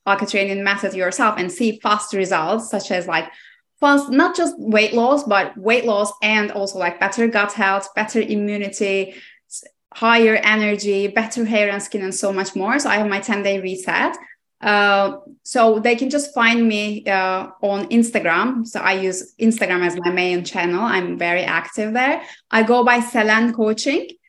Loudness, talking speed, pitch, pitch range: -18 LUFS, 175 wpm, 210 Hz, 195-230 Hz